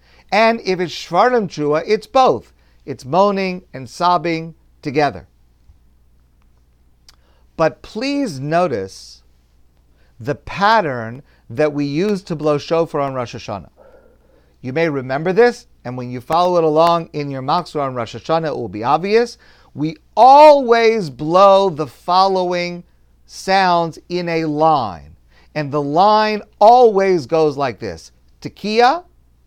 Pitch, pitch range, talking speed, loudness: 155 Hz, 110-185 Hz, 125 wpm, -16 LUFS